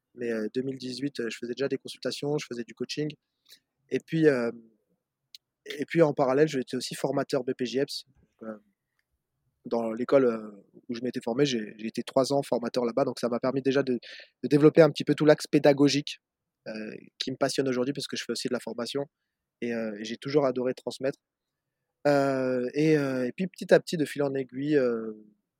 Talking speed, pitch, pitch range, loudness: 190 wpm, 130 Hz, 120-145 Hz, -27 LUFS